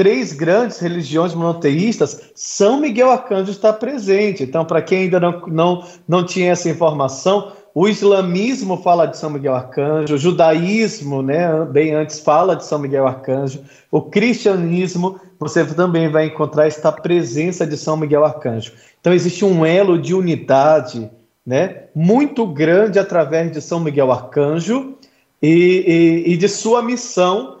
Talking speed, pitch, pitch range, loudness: 150 wpm, 170 Hz, 155-195 Hz, -16 LUFS